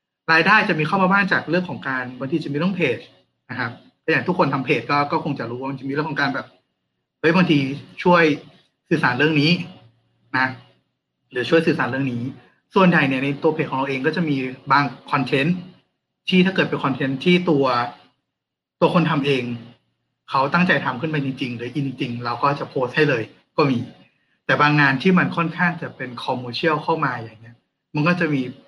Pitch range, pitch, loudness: 130-165 Hz, 145 Hz, -20 LUFS